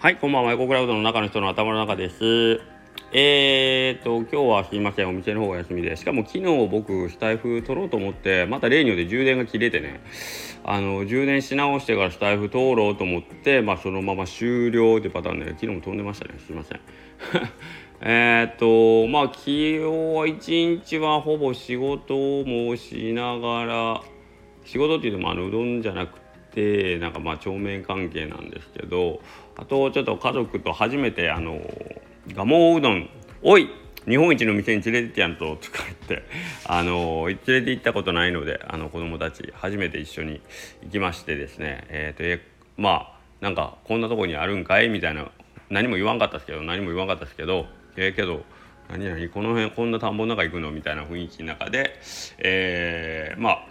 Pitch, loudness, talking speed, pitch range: 105 Hz, -23 LUFS, 380 characters per minute, 90-120 Hz